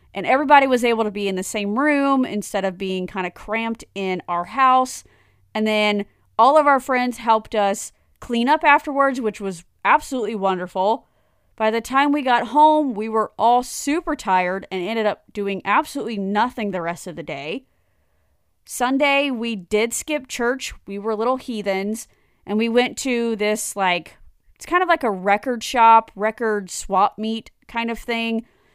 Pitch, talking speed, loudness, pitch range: 220 Hz, 175 wpm, -20 LUFS, 195-250 Hz